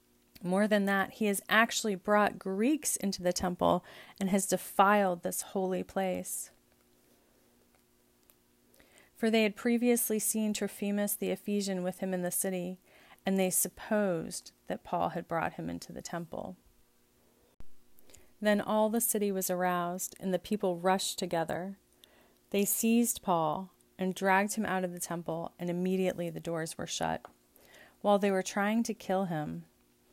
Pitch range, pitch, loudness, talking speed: 165-205 Hz, 185 Hz, -31 LUFS, 150 wpm